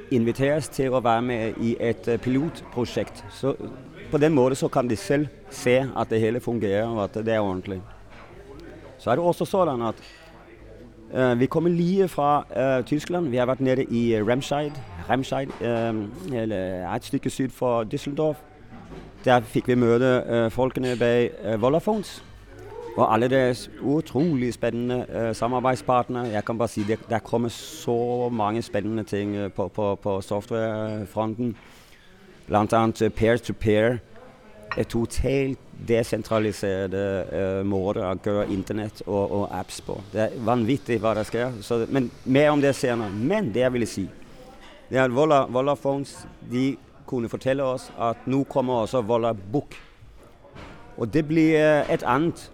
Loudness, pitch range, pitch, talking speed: -24 LUFS, 110-135 Hz, 120 Hz, 160 wpm